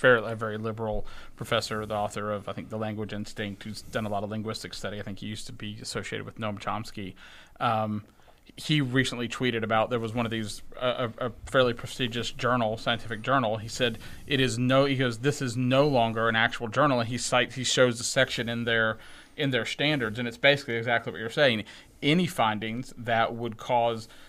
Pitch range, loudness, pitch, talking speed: 110-125 Hz, -28 LUFS, 115 Hz, 210 wpm